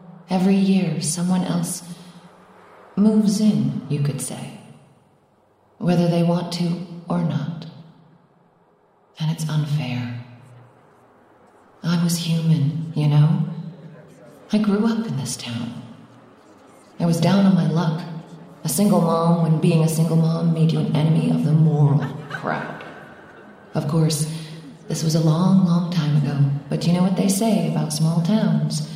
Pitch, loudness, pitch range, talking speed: 165 Hz, -20 LUFS, 155-175 Hz, 145 wpm